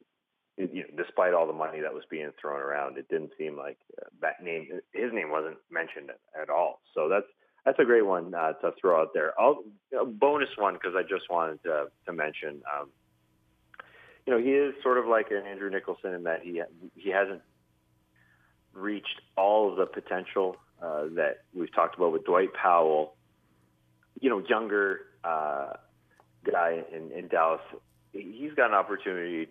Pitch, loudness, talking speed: 85 Hz, -29 LUFS, 175 wpm